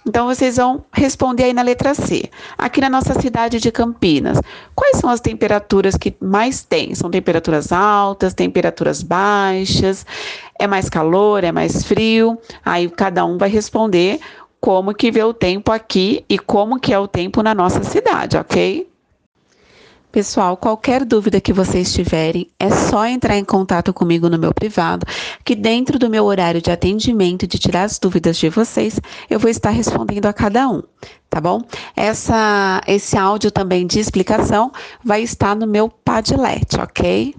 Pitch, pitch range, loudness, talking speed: 210 Hz, 190-230 Hz, -16 LUFS, 165 wpm